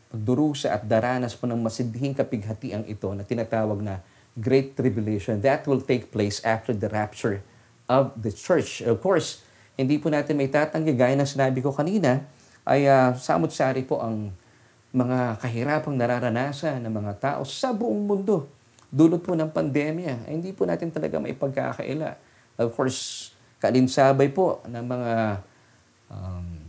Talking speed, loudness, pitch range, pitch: 145 wpm, -25 LUFS, 115-140 Hz, 125 Hz